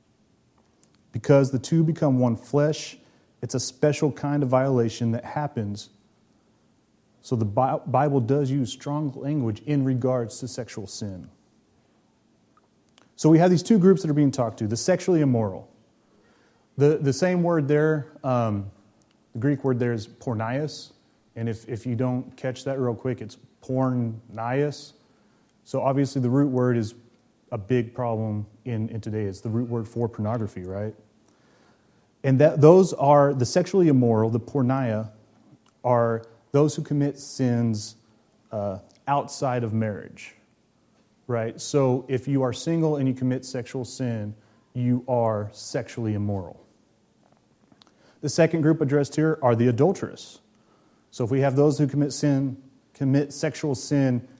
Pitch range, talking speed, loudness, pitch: 115-145 Hz, 150 wpm, -24 LUFS, 130 Hz